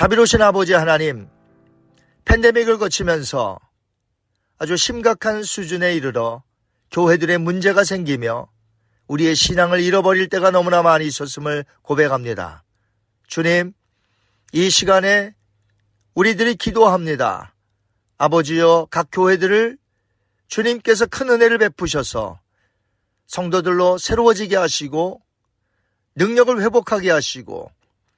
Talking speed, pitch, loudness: 260 characters per minute, 165 Hz, -17 LUFS